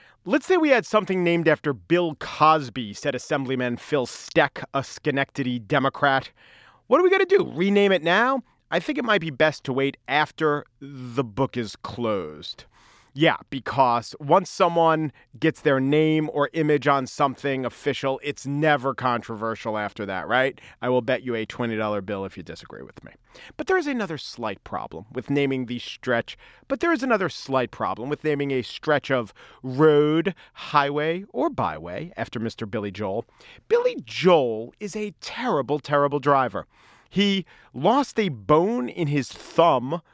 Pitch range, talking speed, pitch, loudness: 125-165 Hz, 165 wpm, 145 Hz, -23 LUFS